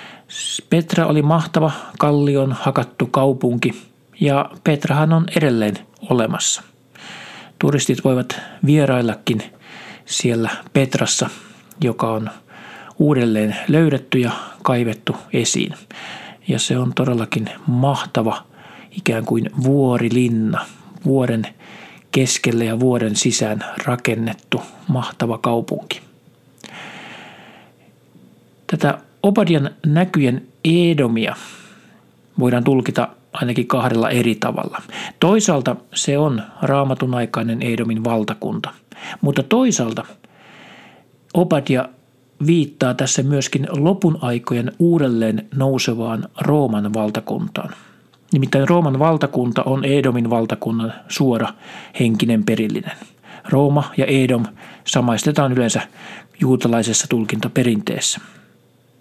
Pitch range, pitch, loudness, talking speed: 120-150 Hz, 130 Hz, -18 LUFS, 85 wpm